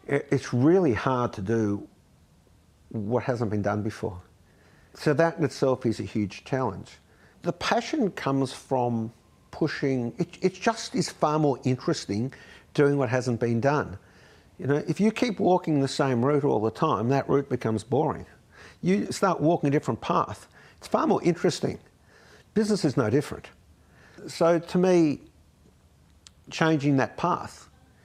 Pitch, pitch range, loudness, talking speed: 130 Hz, 105-150 Hz, -26 LUFS, 150 wpm